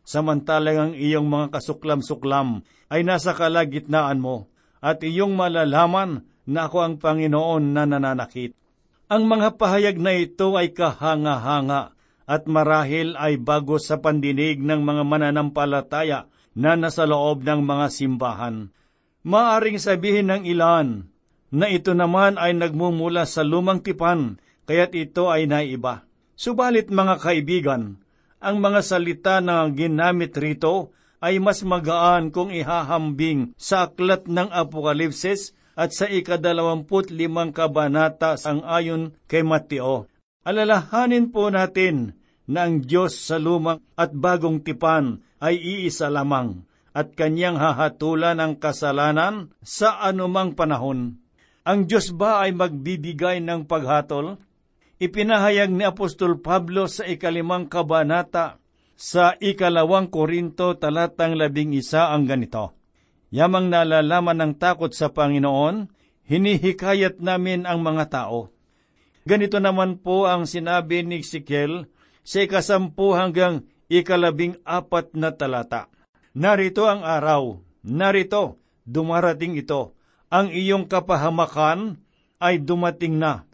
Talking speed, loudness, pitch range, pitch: 120 wpm, -21 LUFS, 150-180 Hz, 165 Hz